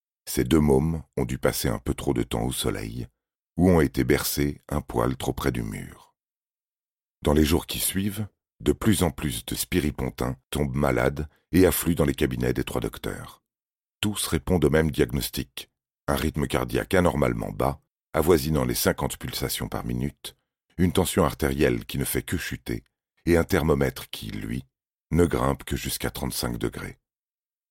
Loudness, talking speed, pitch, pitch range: -25 LUFS, 170 wpm, 75 Hz, 65-85 Hz